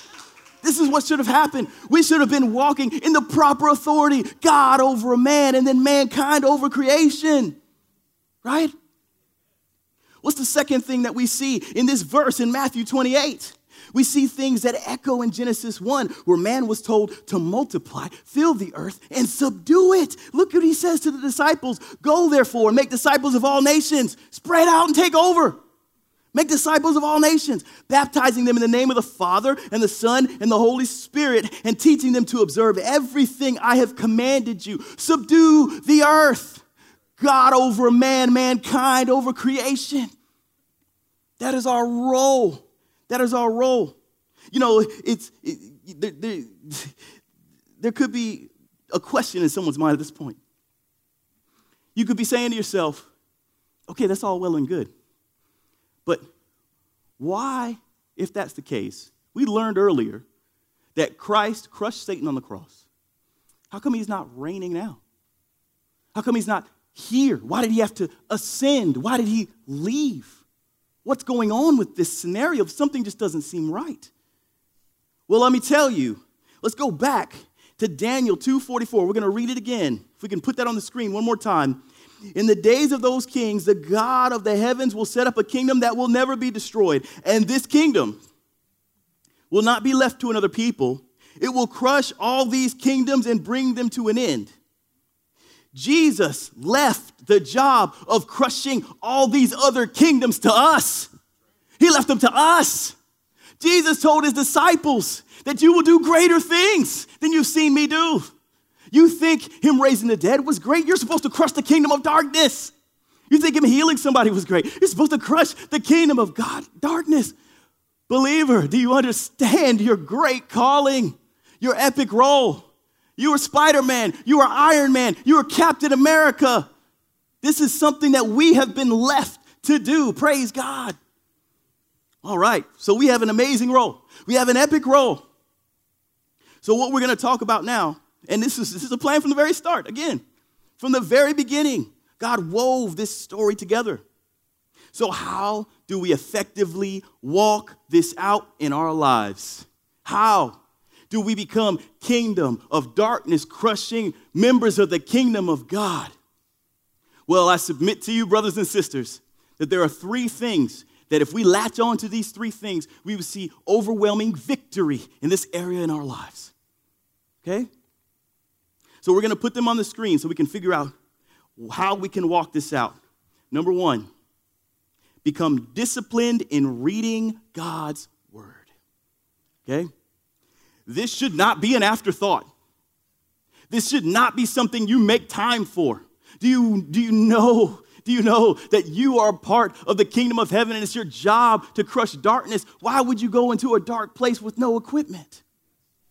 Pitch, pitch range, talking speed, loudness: 250 Hz, 215-285 Hz, 170 wpm, -20 LUFS